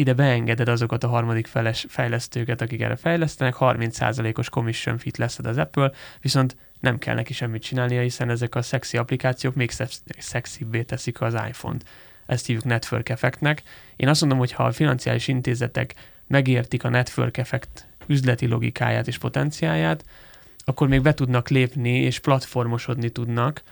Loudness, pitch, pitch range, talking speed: -23 LUFS, 125 Hz, 120-135 Hz, 155 wpm